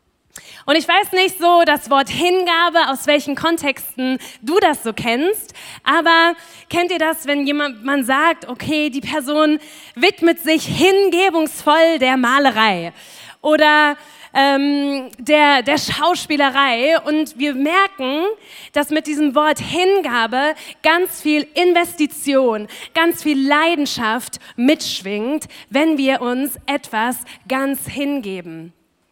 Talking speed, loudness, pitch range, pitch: 115 wpm, -16 LUFS, 270-330 Hz, 295 Hz